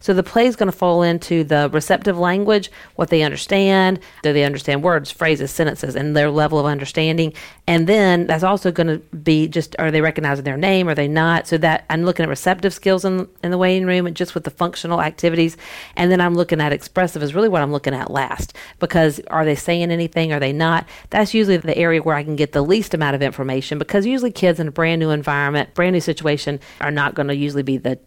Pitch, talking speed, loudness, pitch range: 165 Hz, 235 wpm, -18 LUFS, 150-180 Hz